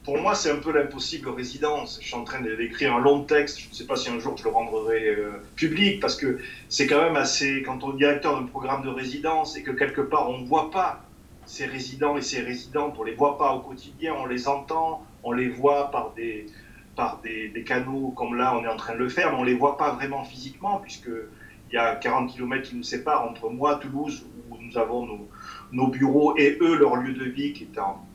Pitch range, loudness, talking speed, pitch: 125-145 Hz, -25 LUFS, 245 wpm, 135 Hz